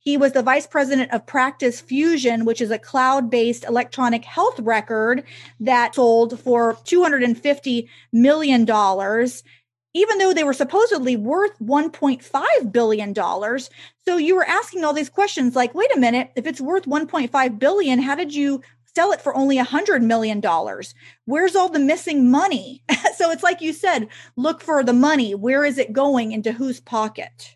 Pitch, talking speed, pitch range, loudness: 265 Hz, 165 wpm, 235-305 Hz, -19 LUFS